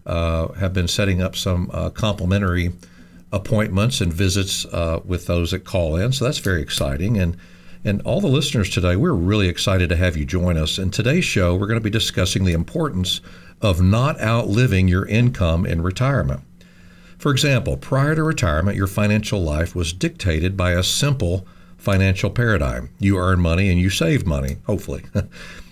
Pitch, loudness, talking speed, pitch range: 95 Hz, -20 LUFS, 175 wpm, 85-105 Hz